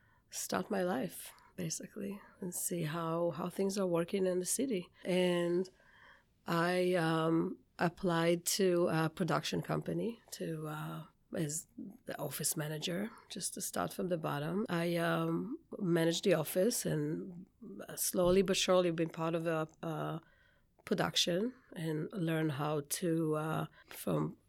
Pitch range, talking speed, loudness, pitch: 165-185 Hz, 135 wpm, -35 LUFS, 175 Hz